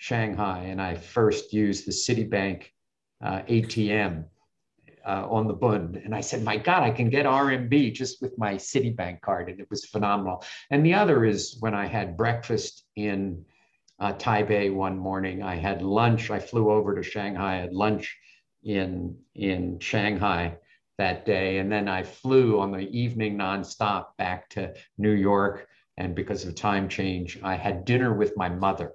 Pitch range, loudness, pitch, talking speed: 95-110 Hz, -26 LUFS, 100 Hz, 170 wpm